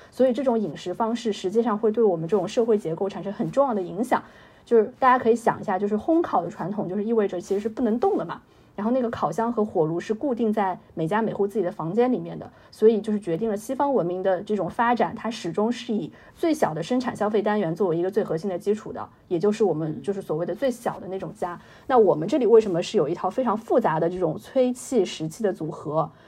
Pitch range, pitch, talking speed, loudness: 185-235 Hz, 210 Hz, 380 characters per minute, -24 LUFS